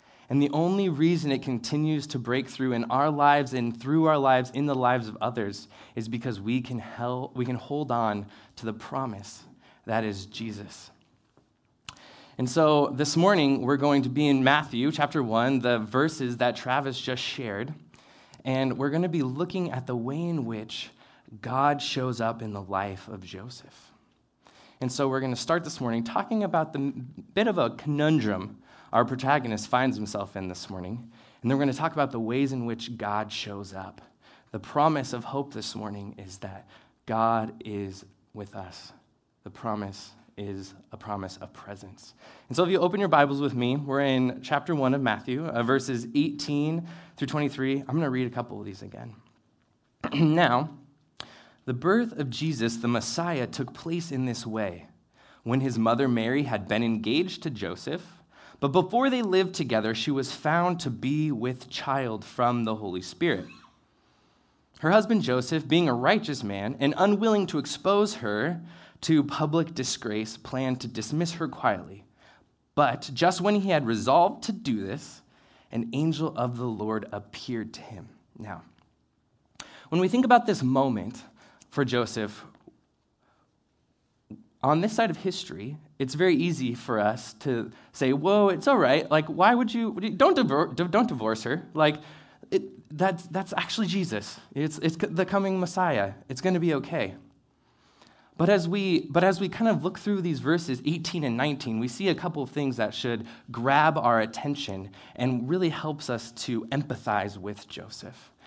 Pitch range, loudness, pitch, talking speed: 115-155 Hz, -27 LUFS, 130 Hz, 175 wpm